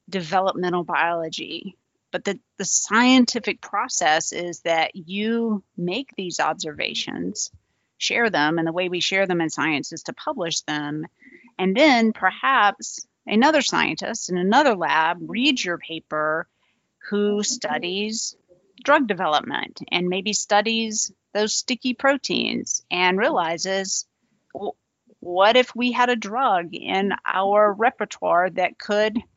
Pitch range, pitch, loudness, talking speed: 175-230 Hz, 195 Hz, -22 LUFS, 125 wpm